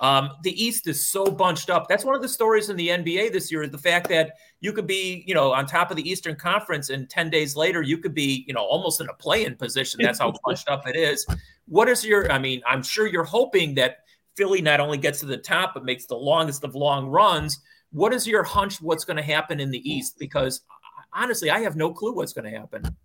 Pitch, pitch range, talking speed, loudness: 165 Hz, 145-200 Hz, 255 wpm, -23 LUFS